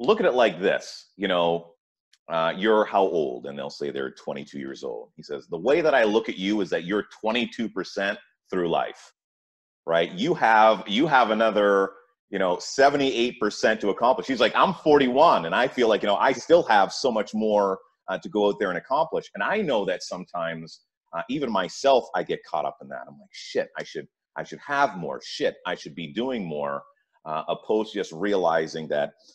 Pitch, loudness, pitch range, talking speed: 95 Hz, -24 LUFS, 80-110 Hz, 215 wpm